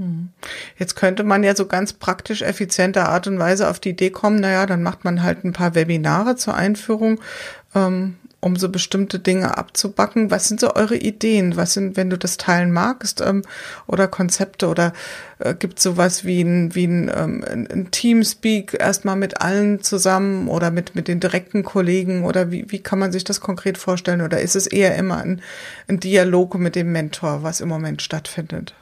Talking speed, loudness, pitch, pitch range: 190 wpm, -19 LUFS, 190 Hz, 180-200 Hz